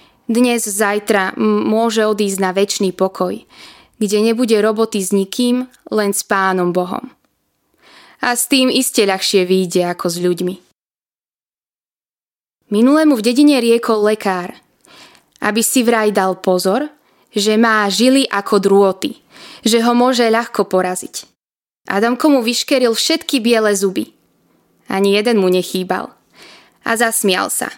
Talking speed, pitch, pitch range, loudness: 125 wpm, 215 Hz, 195-240 Hz, -15 LUFS